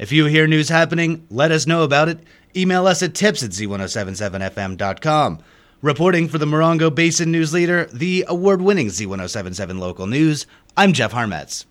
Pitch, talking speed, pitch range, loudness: 155 Hz, 160 wpm, 105-170 Hz, -18 LUFS